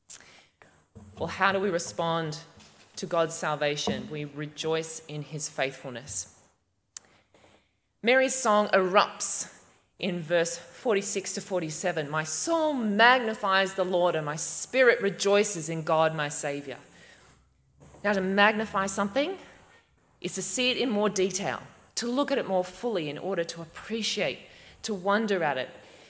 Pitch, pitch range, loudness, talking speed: 180 Hz, 150-205 Hz, -27 LUFS, 135 wpm